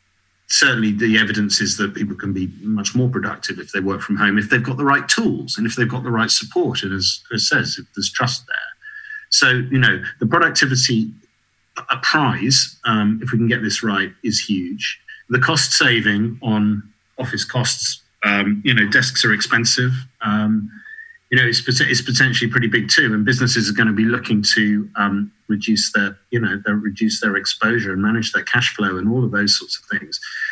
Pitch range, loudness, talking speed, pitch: 105-125 Hz, -17 LUFS, 205 wpm, 115 Hz